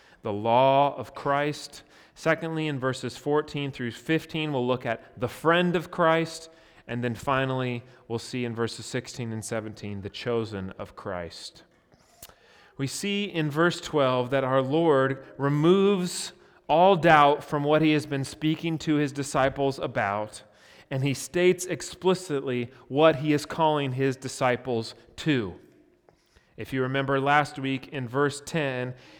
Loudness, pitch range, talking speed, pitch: -26 LUFS, 125-155 Hz, 145 wpm, 135 Hz